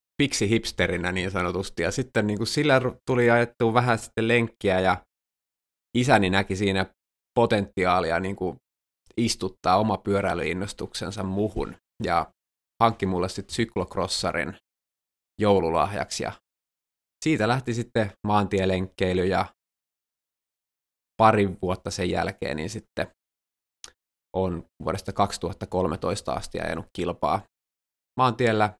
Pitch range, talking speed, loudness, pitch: 90-115 Hz, 105 wpm, -25 LUFS, 95 Hz